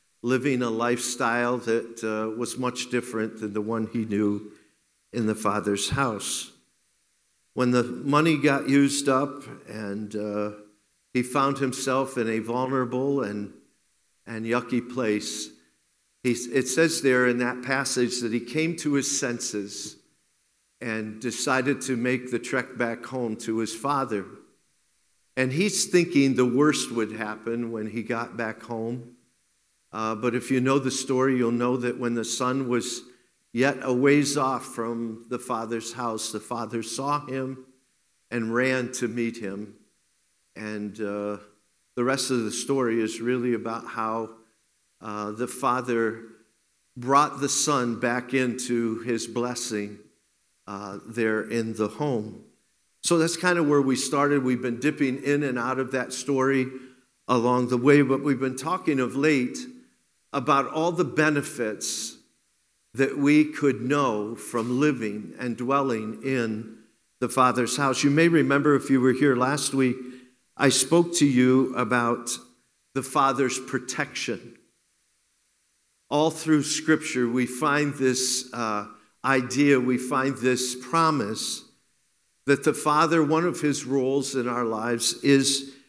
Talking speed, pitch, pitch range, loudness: 145 wpm, 125 Hz, 115-135 Hz, -25 LUFS